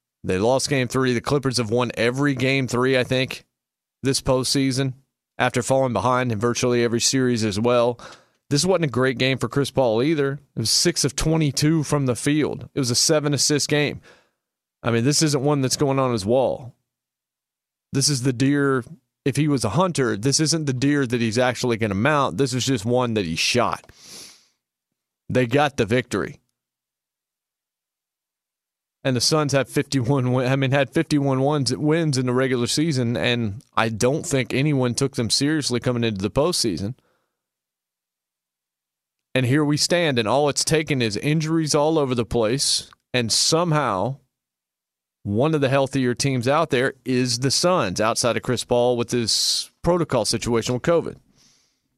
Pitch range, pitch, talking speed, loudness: 120-145 Hz, 130 Hz, 175 wpm, -21 LUFS